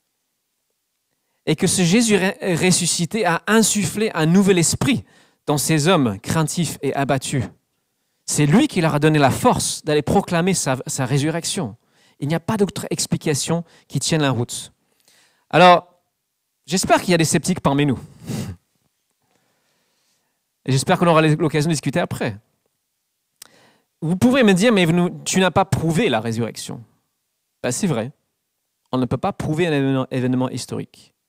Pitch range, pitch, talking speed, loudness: 135-180 Hz, 160 Hz, 155 wpm, -19 LUFS